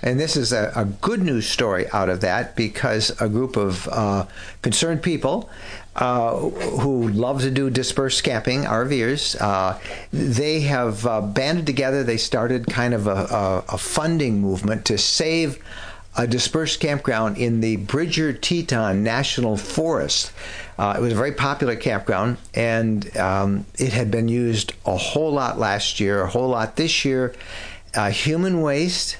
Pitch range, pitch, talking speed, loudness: 105-140 Hz, 120 Hz, 160 wpm, -21 LUFS